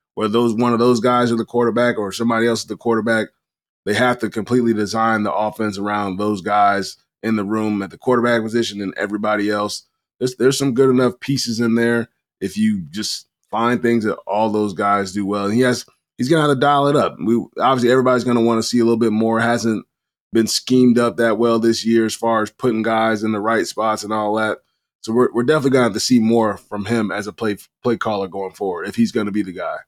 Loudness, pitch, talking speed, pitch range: -18 LUFS, 115 Hz, 245 wpm, 105-120 Hz